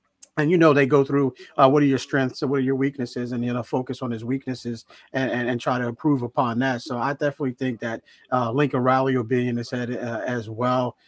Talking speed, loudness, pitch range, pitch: 255 wpm, -23 LUFS, 120-135 Hz, 130 Hz